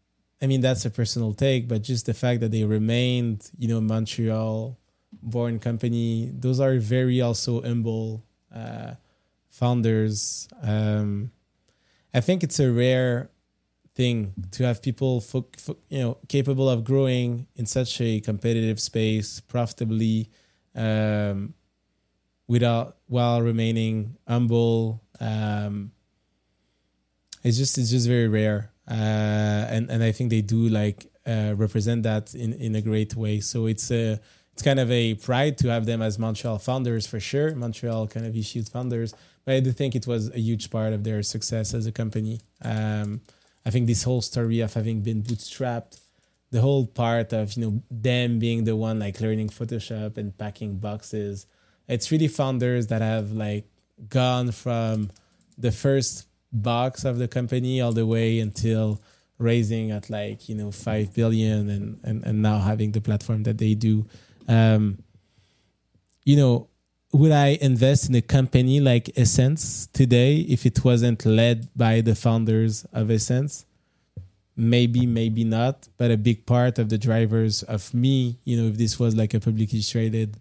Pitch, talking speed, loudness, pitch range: 115 Hz, 160 wpm, -24 LUFS, 110-125 Hz